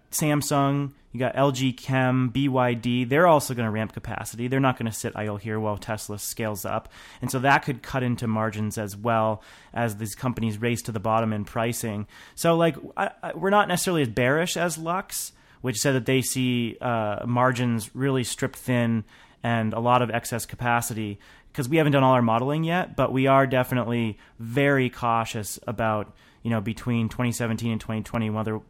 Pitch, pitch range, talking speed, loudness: 120 Hz, 110-135 Hz, 190 wpm, -25 LUFS